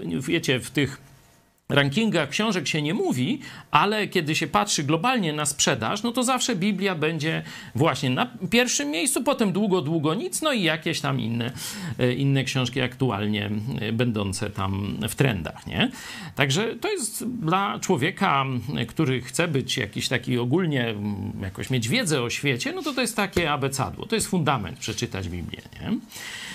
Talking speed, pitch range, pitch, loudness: 155 wpm, 125-190 Hz, 145 Hz, -24 LUFS